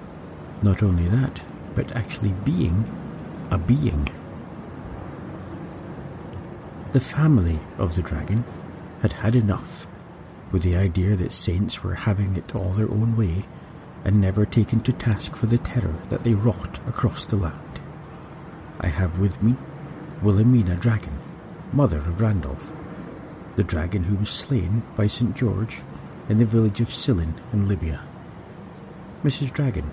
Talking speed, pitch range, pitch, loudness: 135 wpm, 90-120 Hz, 105 Hz, -23 LUFS